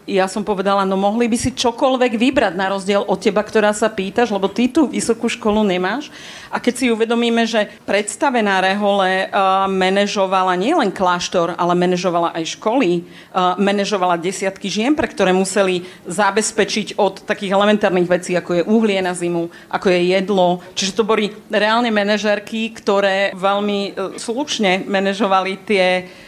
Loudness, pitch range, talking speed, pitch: -17 LUFS, 185-220 Hz, 155 wpm, 200 Hz